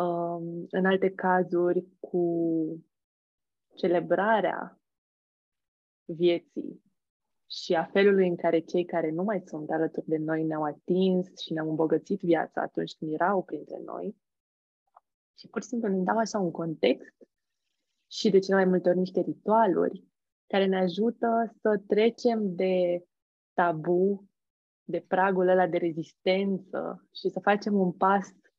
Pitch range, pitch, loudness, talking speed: 170-195 Hz, 180 Hz, -27 LUFS, 135 wpm